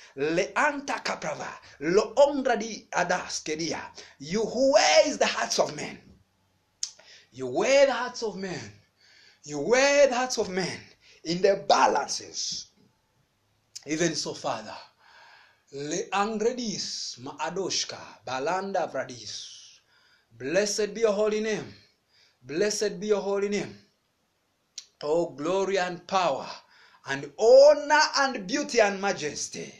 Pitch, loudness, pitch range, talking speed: 205 Hz, -26 LUFS, 165-245 Hz, 105 wpm